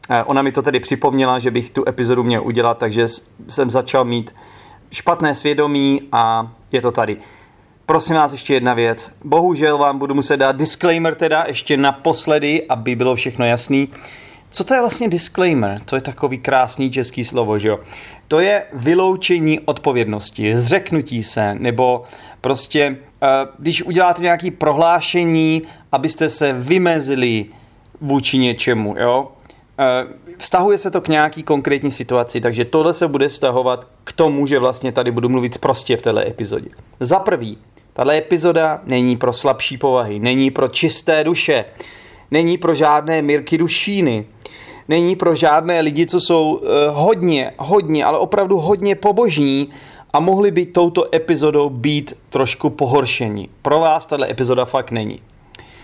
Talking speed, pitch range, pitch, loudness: 145 wpm, 125-165 Hz, 140 Hz, -16 LUFS